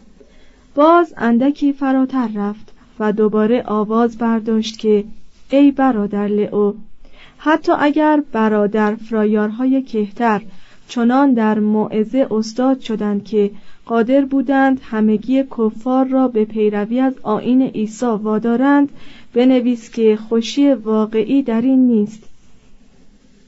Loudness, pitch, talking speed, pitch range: -16 LUFS, 230 Hz, 105 wpm, 215-265 Hz